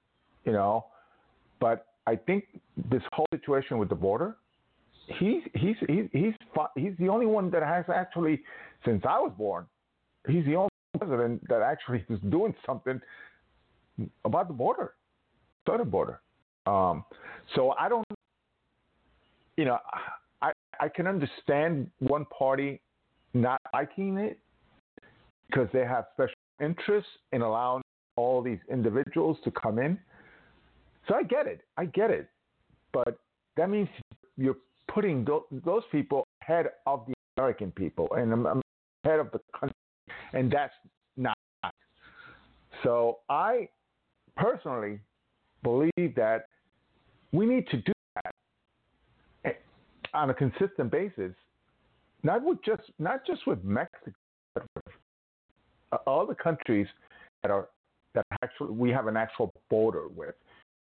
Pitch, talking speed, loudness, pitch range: 140 Hz, 130 wpm, -30 LUFS, 120-175 Hz